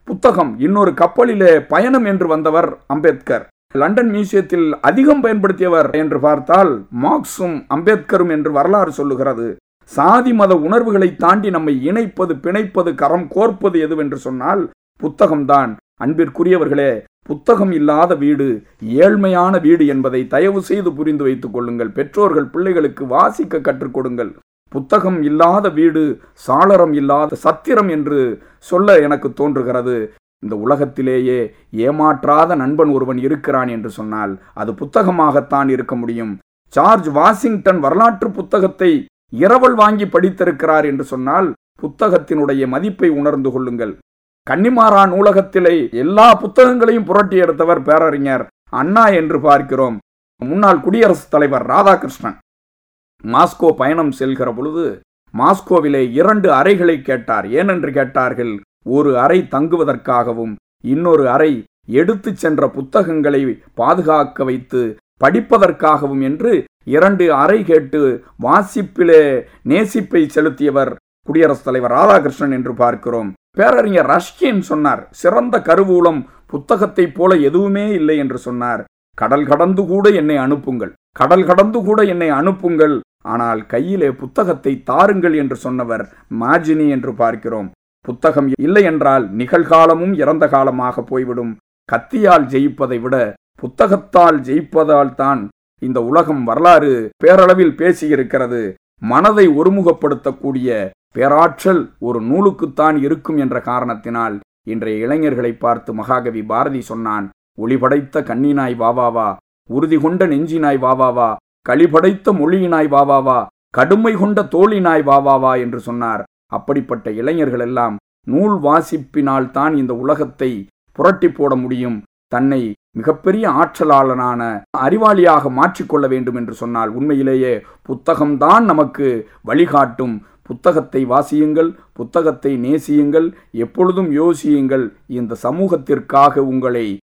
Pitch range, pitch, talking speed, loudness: 130-180 Hz, 150 Hz, 105 wpm, -14 LUFS